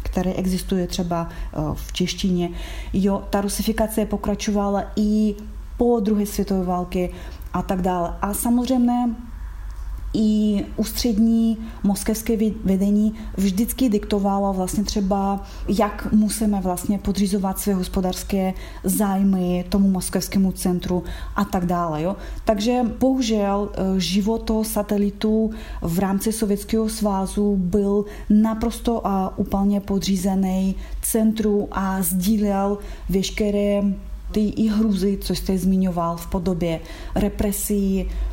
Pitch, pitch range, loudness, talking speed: 200 Hz, 190-215 Hz, -22 LUFS, 105 wpm